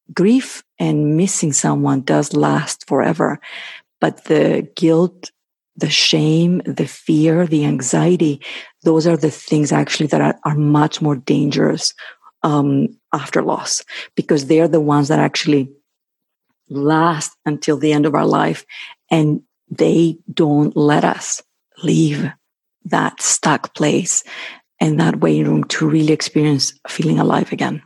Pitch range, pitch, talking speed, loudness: 145-165 Hz, 155 Hz, 135 wpm, -16 LUFS